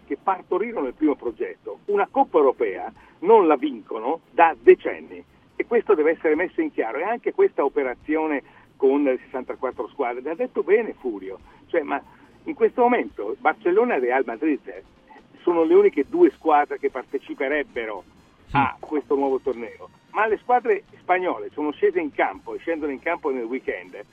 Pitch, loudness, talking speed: 375 Hz, -23 LUFS, 165 wpm